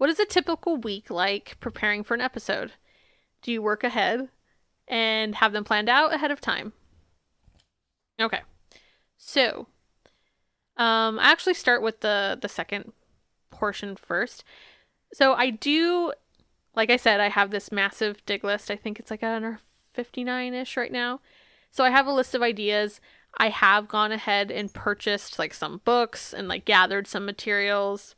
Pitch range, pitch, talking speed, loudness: 205-245 Hz, 220 Hz, 165 wpm, -24 LUFS